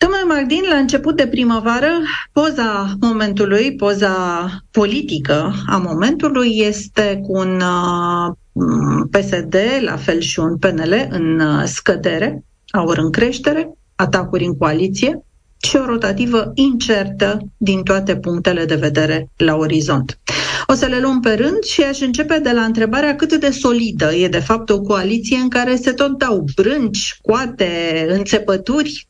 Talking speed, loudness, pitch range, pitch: 140 wpm, -16 LUFS, 175-260 Hz, 210 Hz